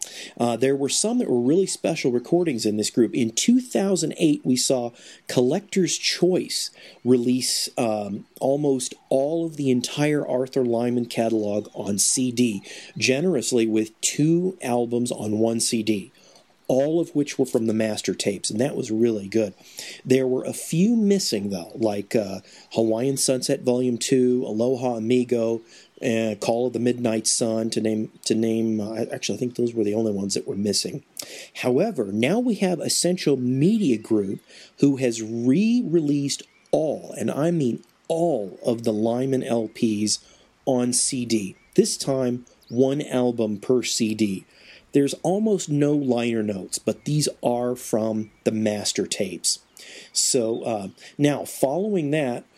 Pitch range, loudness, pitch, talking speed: 110-145 Hz, -23 LUFS, 125 Hz, 150 wpm